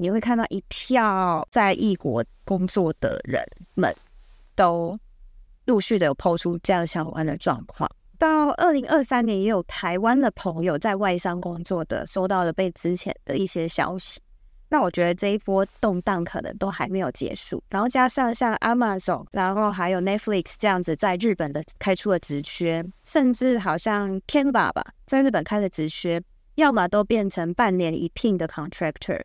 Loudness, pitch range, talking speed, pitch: -24 LUFS, 175-220 Hz, 295 characters per minute, 190 Hz